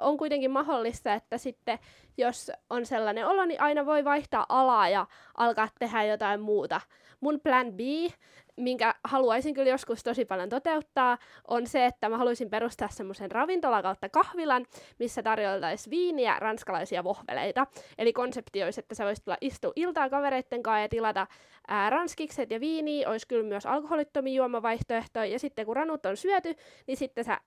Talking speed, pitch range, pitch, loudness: 160 wpm, 220-285 Hz, 245 Hz, -29 LUFS